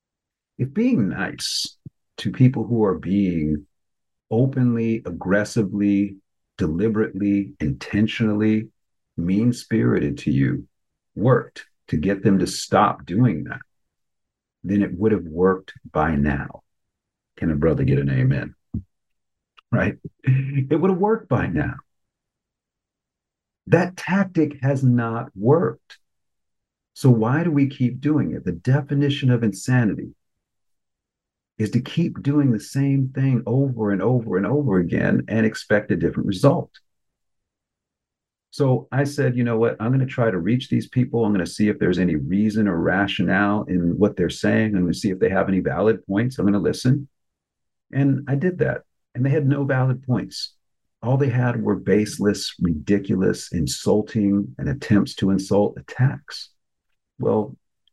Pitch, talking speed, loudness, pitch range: 110 Hz, 150 wpm, -21 LUFS, 95-130 Hz